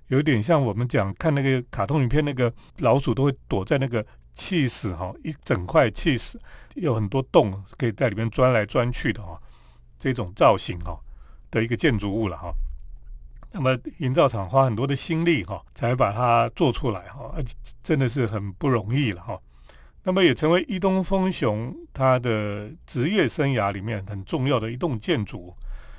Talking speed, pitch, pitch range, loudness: 260 characters per minute, 115 Hz, 95-140 Hz, -24 LUFS